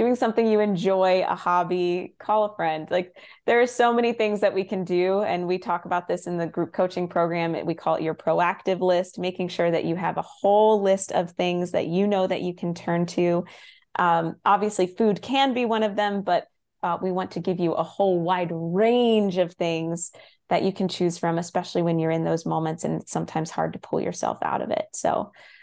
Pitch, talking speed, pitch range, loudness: 180 Hz, 225 wpm, 170-200 Hz, -24 LUFS